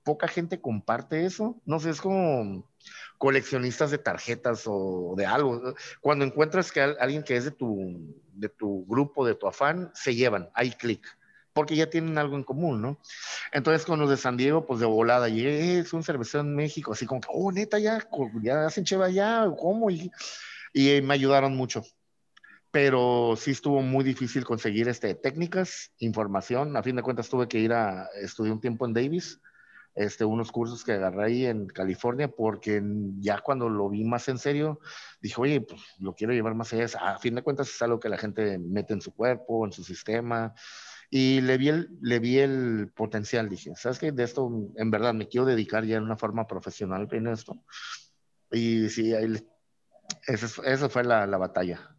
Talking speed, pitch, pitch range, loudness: 190 wpm, 125 Hz, 110-145 Hz, -28 LUFS